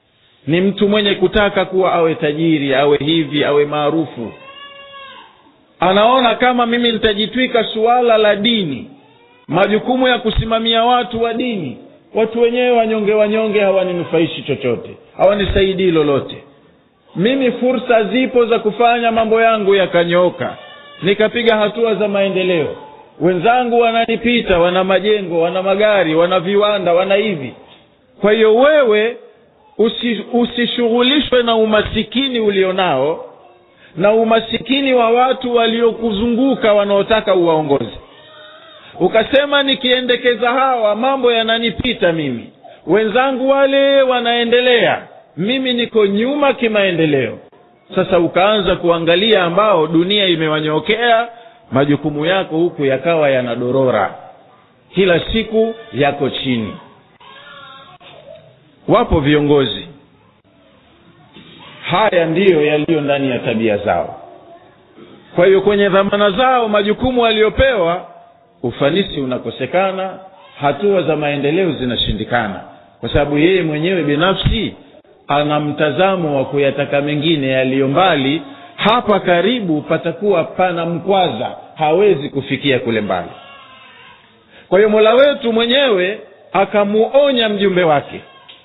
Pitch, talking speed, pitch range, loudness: 205 Hz, 100 wpm, 165-235 Hz, -14 LUFS